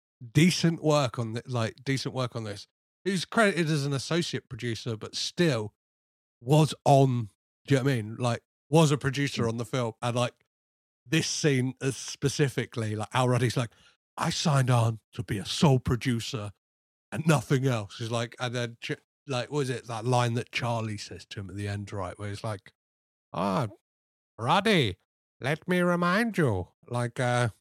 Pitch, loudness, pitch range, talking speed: 120 Hz, -28 LUFS, 110-140 Hz, 185 wpm